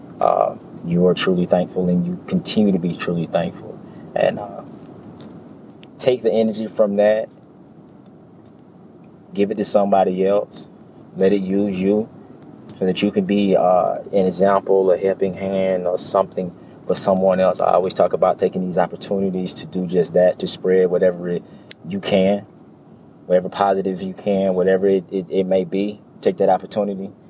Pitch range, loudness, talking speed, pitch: 95-100 Hz, -19 LUFS, 165 wpm, 95 Hz